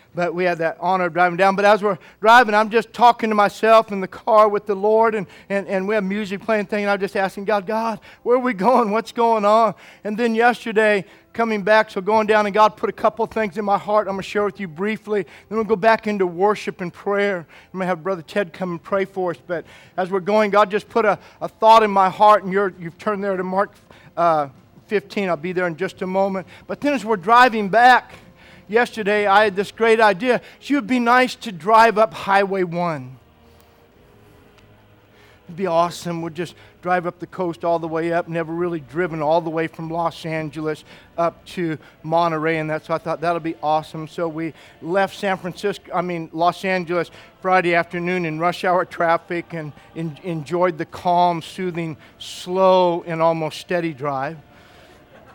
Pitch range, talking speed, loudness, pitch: 165-210 Hz, 210 wpm, -19 LUFS, 185 Hz